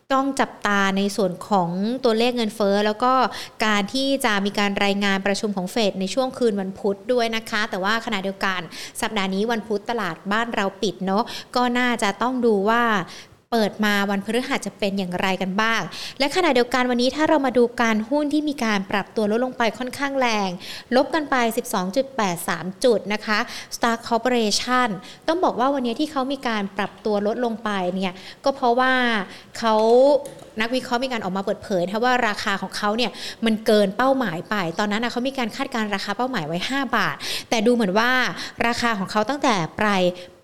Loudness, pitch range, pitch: -22 LUFS, 200-250 Hz, 225 Hz